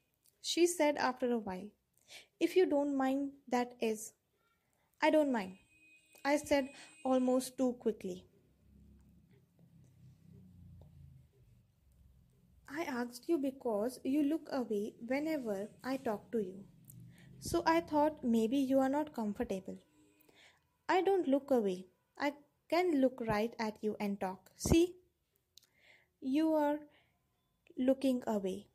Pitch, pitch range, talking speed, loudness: 240 Hz, 185-285 Hz, 115 wpm, -35 LUFS